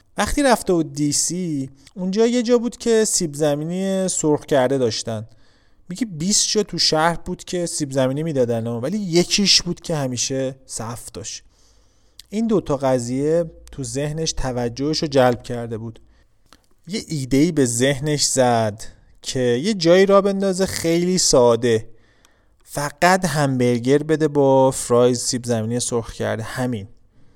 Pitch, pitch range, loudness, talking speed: 140 Hz, 120-175 Hz, -19 LUFS, 140 wpm